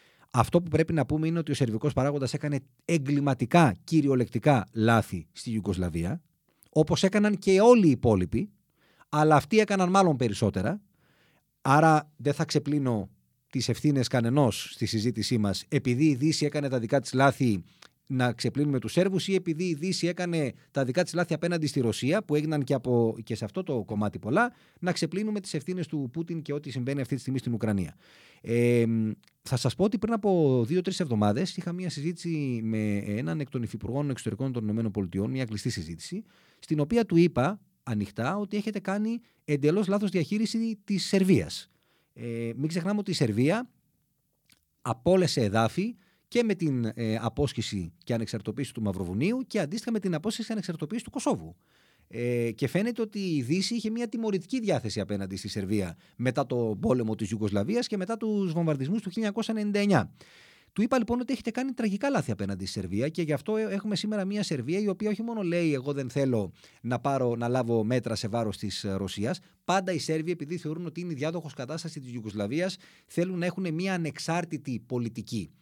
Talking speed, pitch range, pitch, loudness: 175 wpm, 115-185 Hz, 150 Hz, -28 LUFS